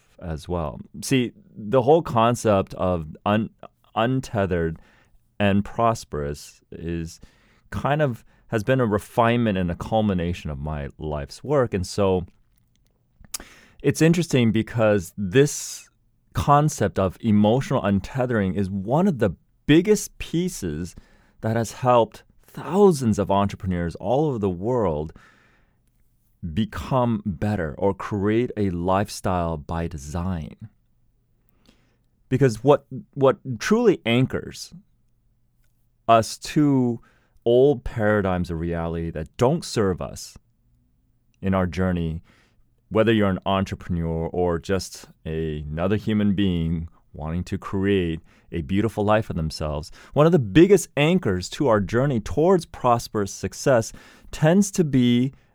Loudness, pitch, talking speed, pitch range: -23 LUFS, 105 Hz, 120 wpm, 90-120 Hz